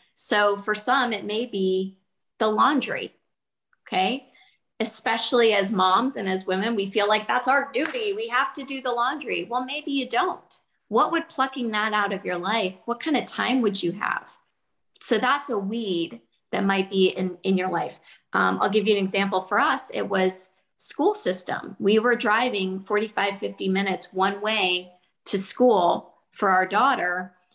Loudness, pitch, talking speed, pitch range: -24 LUFS, 205 Hz, 175 wpm, 190-240 Hz